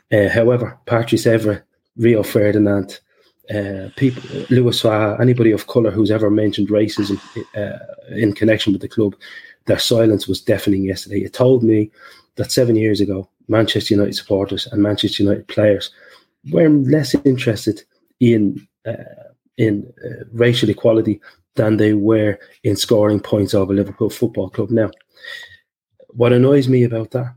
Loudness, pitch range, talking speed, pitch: -17 LUFS, 100-120 Hz, 145 wpm, 110 Hz